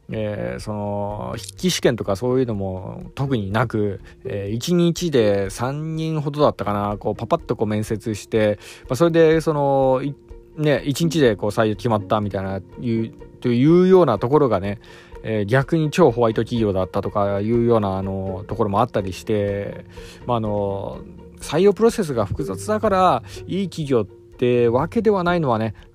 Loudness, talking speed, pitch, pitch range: -20 LUFS, 320 characters per minute, 115 Hz, 100-150 Hz